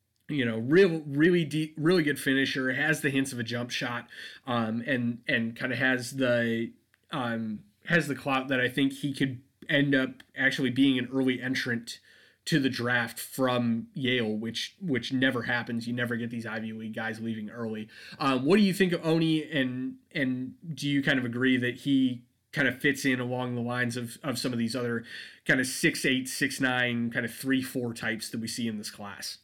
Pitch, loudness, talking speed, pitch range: 130 Hz, -28 LUFS, 210 wpm, 120-140 Hz